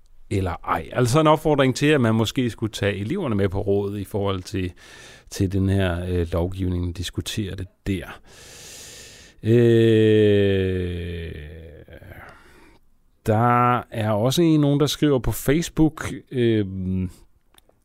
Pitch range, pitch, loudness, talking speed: 95-120 Hz, 100 Hz, -21 LUFS, 130 wpm